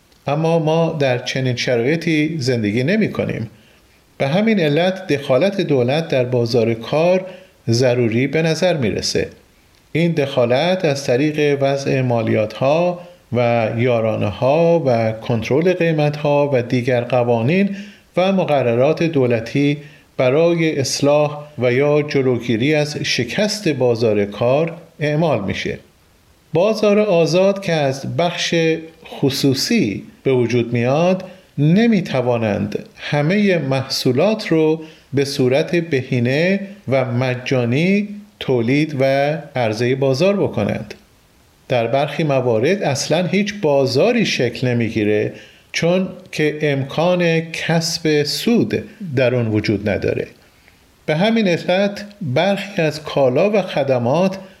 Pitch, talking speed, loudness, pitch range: 145 Hz, 110 wpm, -17 LUFS, 125-170 Hz